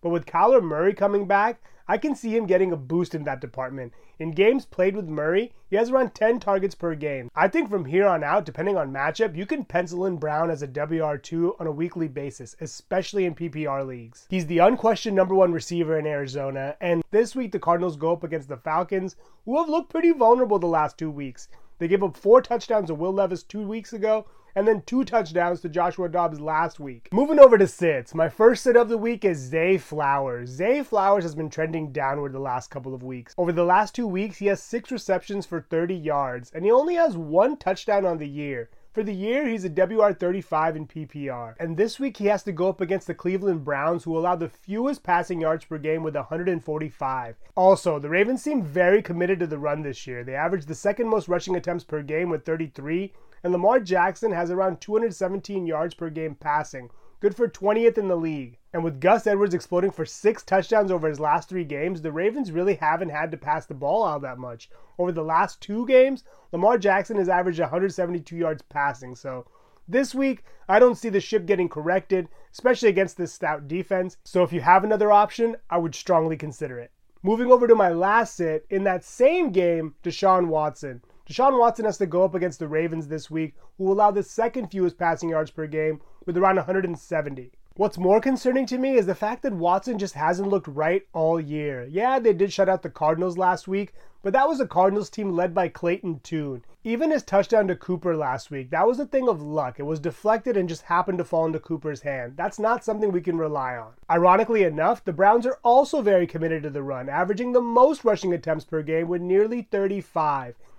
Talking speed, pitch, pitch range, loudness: 215 wpm, 180 Hz, 155-210 Hz, -23 LUFS